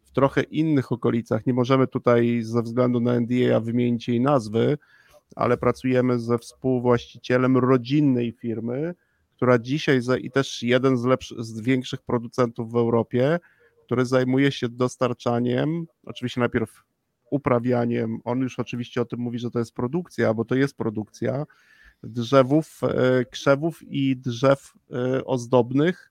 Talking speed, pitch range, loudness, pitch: 135 wpm, 120-135 Hz, -23 LUFS, 125 Hz